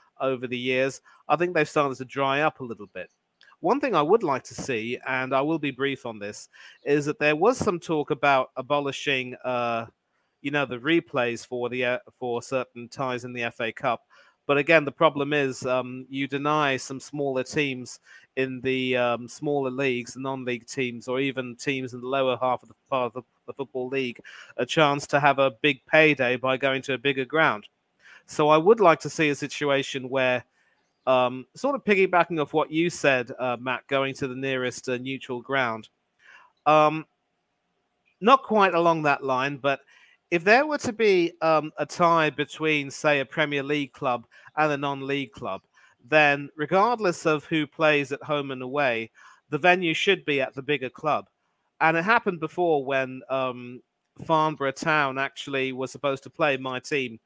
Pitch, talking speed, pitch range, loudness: 140 Hz, 190 wpm, 130-150 Hz, -25 LUFS